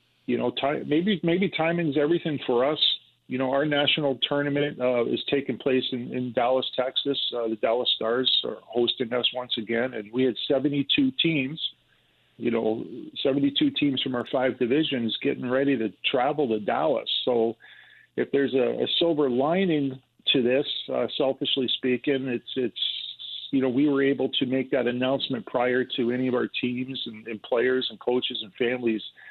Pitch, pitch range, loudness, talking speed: 130 Hz, 120-145 Hz, -25 LUFS, 175 wpm